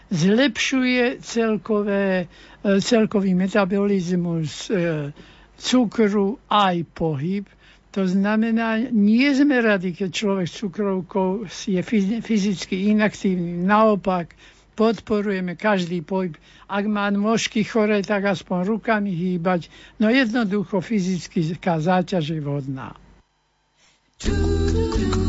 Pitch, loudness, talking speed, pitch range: 200 Hz, -21 LUFS, 90 wpm, 180-215 Hz